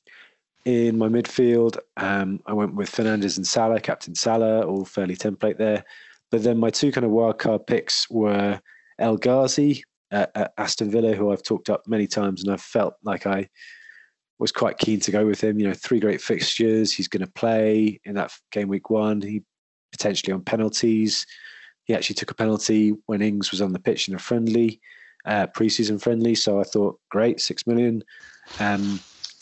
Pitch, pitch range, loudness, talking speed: 110 Hz, 100-115 Hz, -23 LUFS, 185 wpm